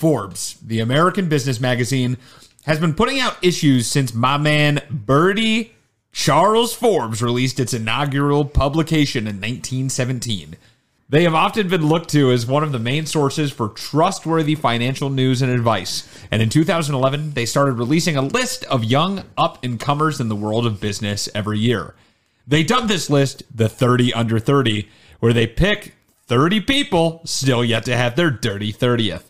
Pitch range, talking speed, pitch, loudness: 120-155 Hz, 165 wpm, 135 Hz, -18 LUFS